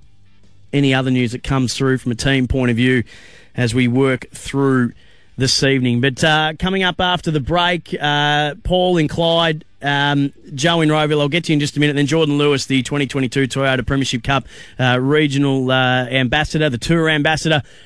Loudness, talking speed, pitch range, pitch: -17 LUFS, 190 wpm, 125-155 Hz, 140 Hz